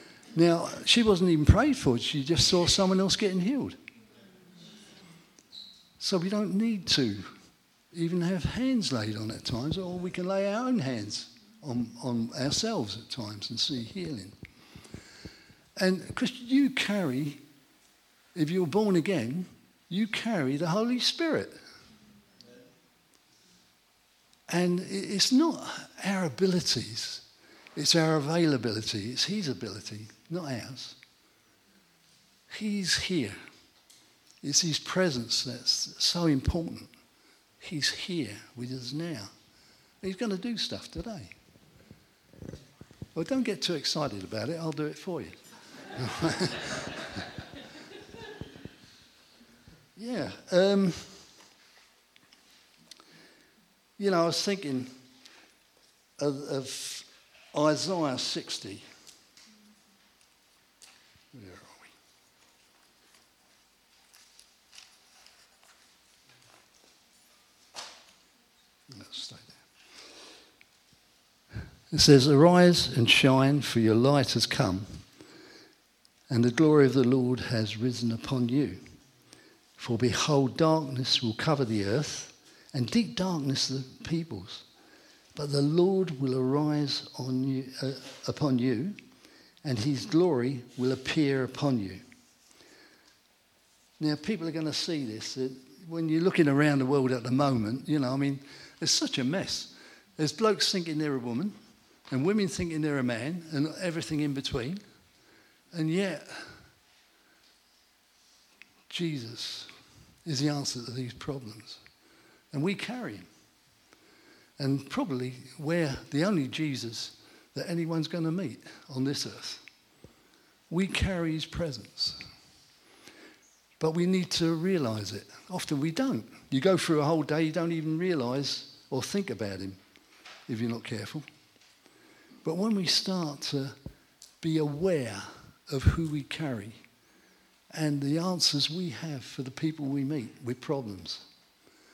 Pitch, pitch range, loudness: 150 Hz, 130-180 Hz, -29 LUFS